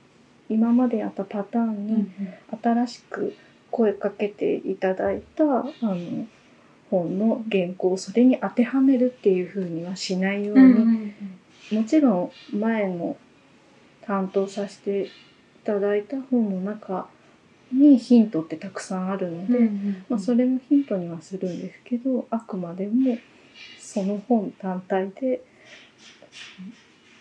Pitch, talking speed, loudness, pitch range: 210 Hz, 245 characters per minute, -24 LUFS, 195-240 Hz